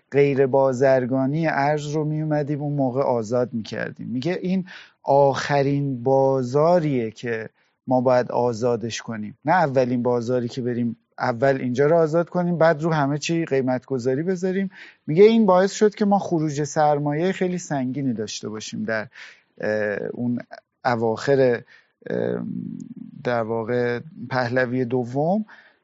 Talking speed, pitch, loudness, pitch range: 130 wpm, 135 Hz, -22 LUFS, 125-155 Hz